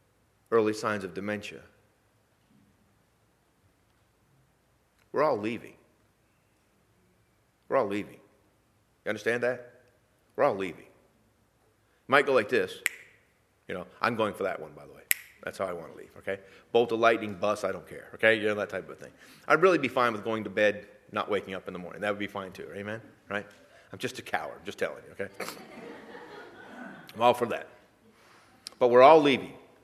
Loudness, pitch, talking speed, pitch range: -28 LUFS, 110 Hz, 180 wpm, 105-125 Hz